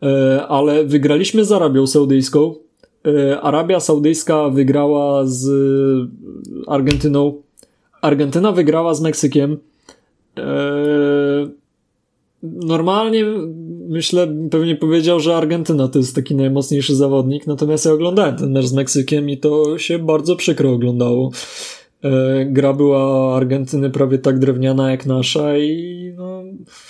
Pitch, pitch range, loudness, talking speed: 145 Hz, 135-160 Hz, -15 LUFS, 105 wpm